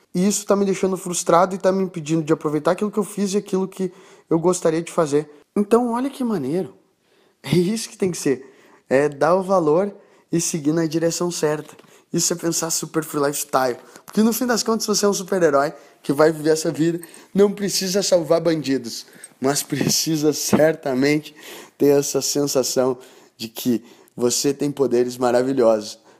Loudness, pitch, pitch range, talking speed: -20 LUFS, 165 Hz, 145-190 Hz, 180 wpm